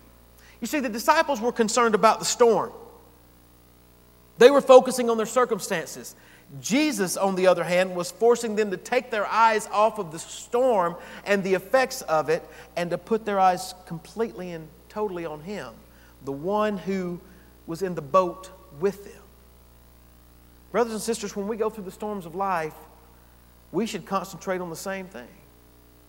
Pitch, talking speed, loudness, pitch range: 185 Hz, 170 wpm, -24 LUFS, 130-215 Hz